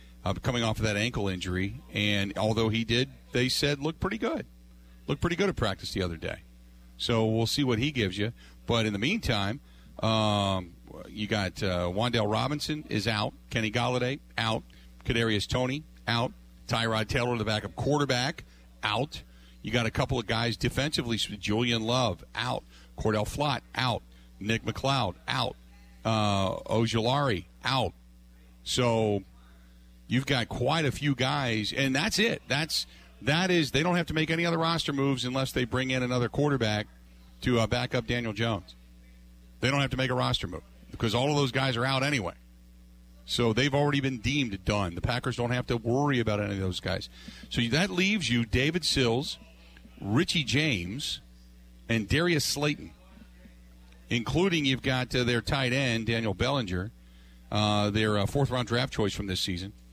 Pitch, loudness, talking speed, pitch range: 115 Hz, -28 LUFS, 170 wpm, 90-130 Hz